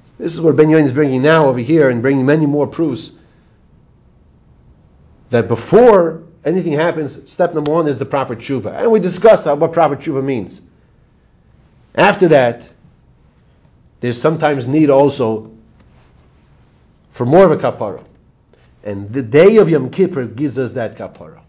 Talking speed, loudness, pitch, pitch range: 155 wpm, -14 LUFS, 140 Hz, 125-160 Hz